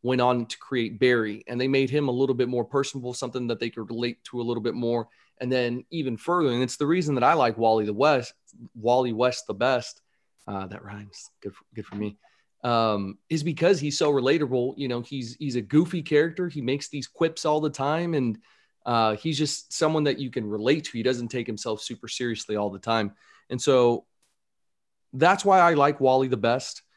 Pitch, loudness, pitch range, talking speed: 125 Hz, -25 LUFS, 115-145 Hz, 220 wpm